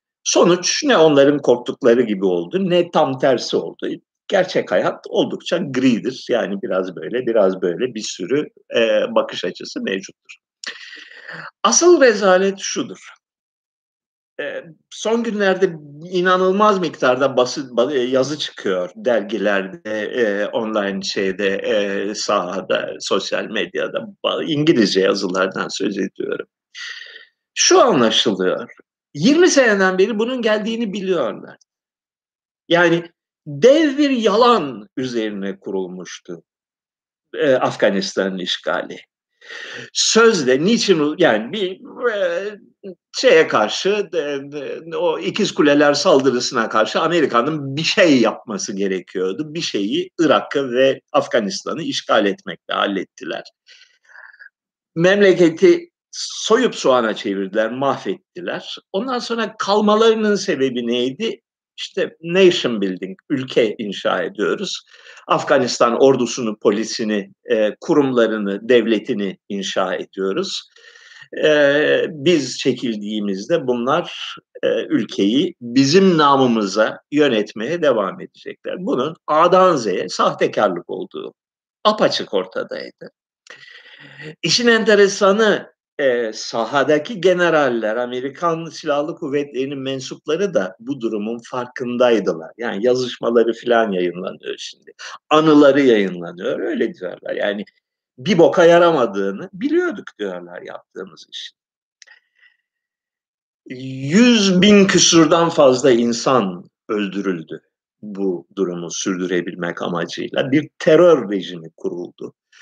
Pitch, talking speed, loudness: 170 Hz, 95 wpm, -17 LUFS